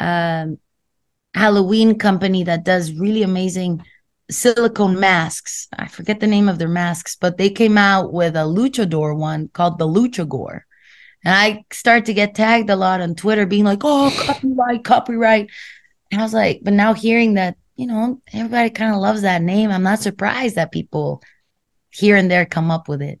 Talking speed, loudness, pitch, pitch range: 185 wpm, -17 LUFS, 200 Hz, 175-220 Hz